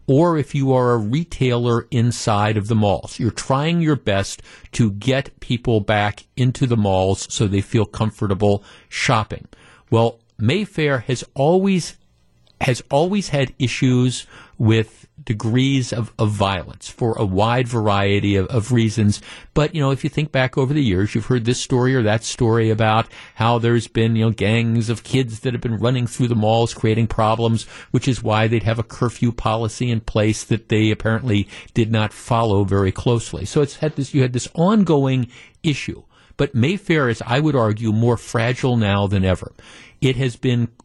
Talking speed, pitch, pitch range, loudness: 180 wpm, 115 Hz, 110-130 Hz, -19 LUFS